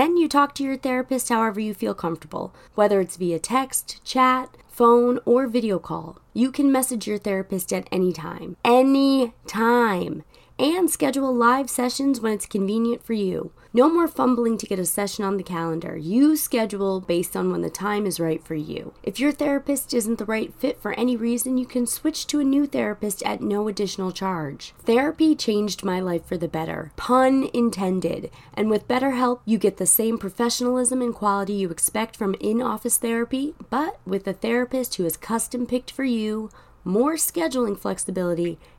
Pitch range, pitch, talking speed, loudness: 195-255 Hz, 230 Hz, 185 wpm, -23 LUFS